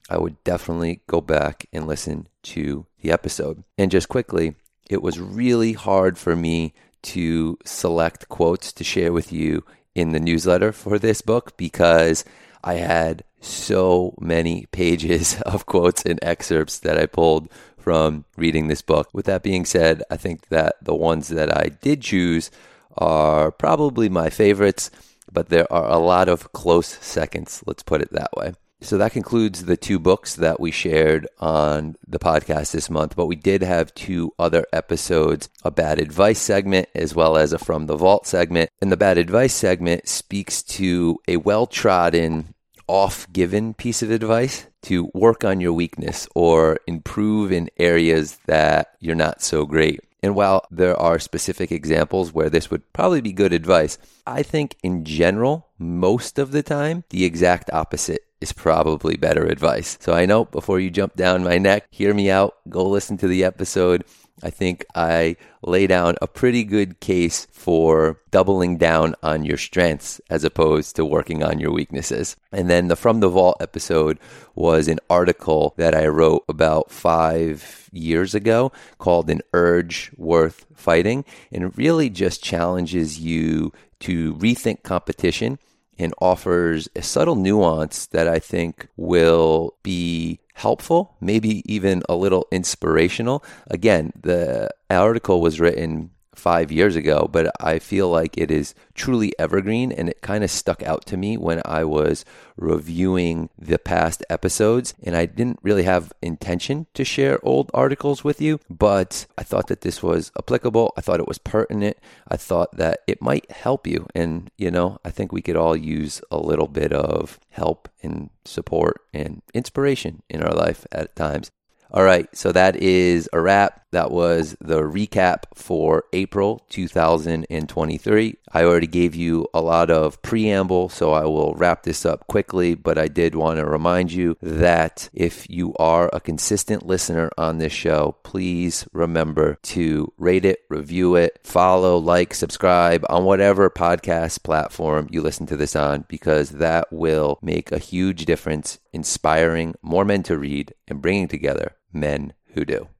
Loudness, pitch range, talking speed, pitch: -20 LUFS, 80-95 Hz, 165 wpm, 85 Hz